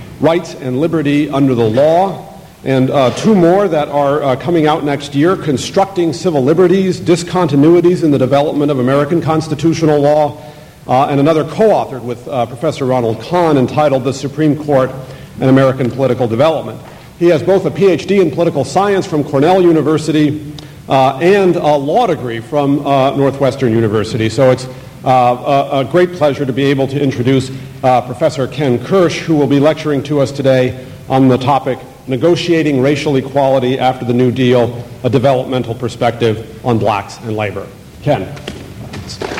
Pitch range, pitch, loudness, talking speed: 130-160 Hz, 140 Hz, -13 LUFS, 160 wpm